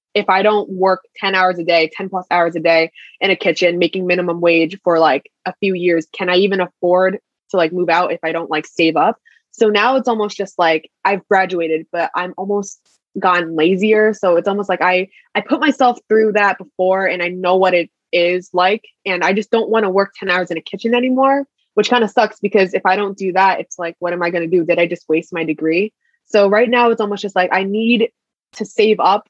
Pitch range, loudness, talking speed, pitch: 175-210 Hz, -16 LUFS, 240 wpm, 190 Hz